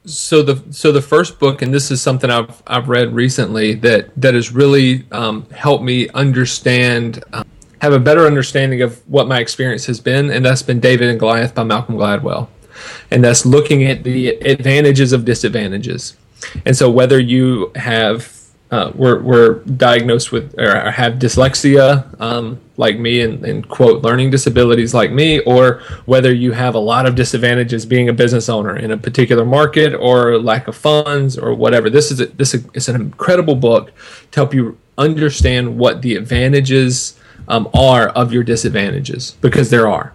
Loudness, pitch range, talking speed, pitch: -13 LUFS, 120-135 Hz, 175 wpm, 125 Hz